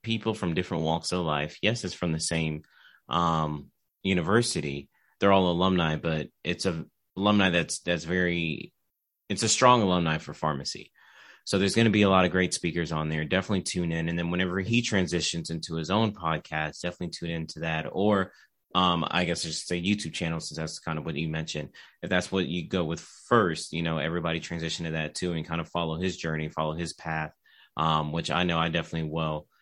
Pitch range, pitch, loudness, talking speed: 80-90 Hz, 85 Hz, -28 LUFS, 205 wpm